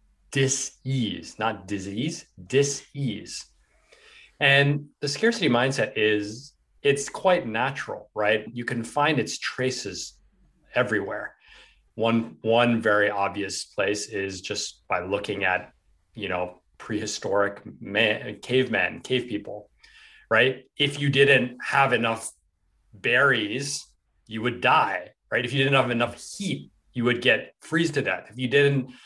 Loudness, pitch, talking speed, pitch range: -24 LUFS, 120 Hz, 130 wpm, 105-135 Hz